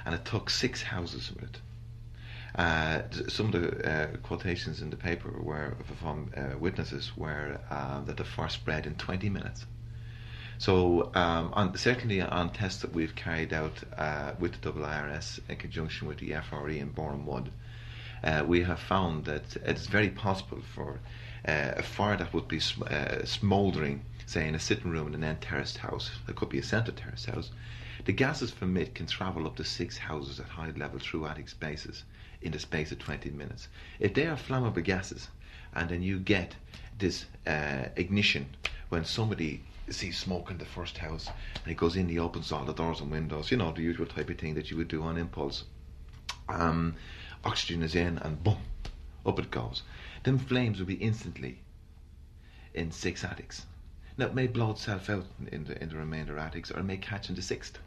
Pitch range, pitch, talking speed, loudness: 80-105 Hz, 85 Hz, 195 wpm, -33 LUFS